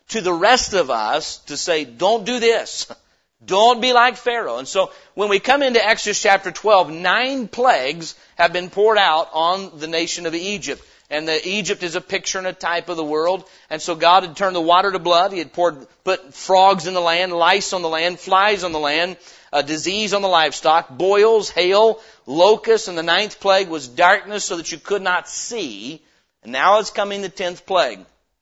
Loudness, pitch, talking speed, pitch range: -18 LUFS, 185 Hz, 205 wpm, 165-205 Hz